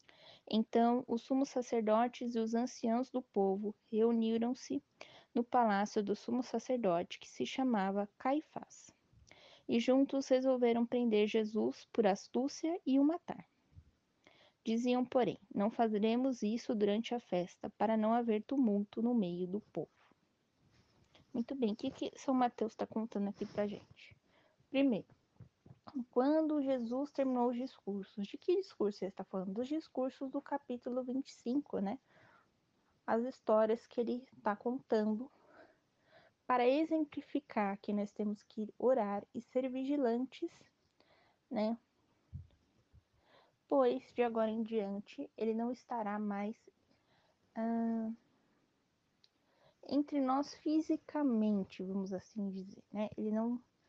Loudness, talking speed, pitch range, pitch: -36 LUFS, 125 wpm, 215-265 Hz, 240 Hz